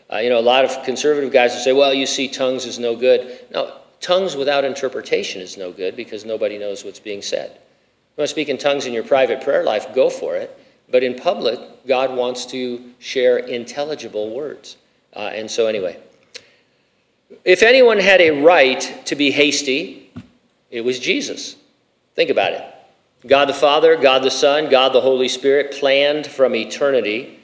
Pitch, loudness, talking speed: 145 Hz, -17 LUFS, 185 wpm